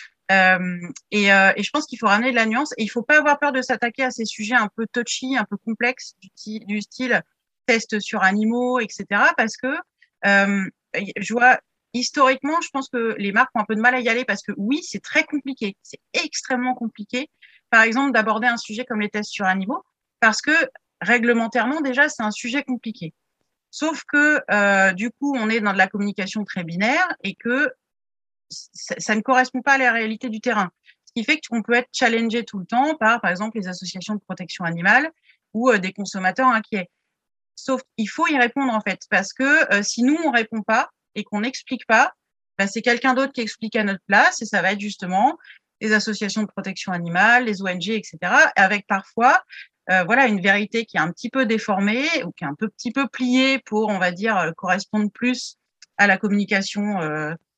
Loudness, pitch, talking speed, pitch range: -20 LUFS, 225 Hz, 215 wpm, 205-255 Hz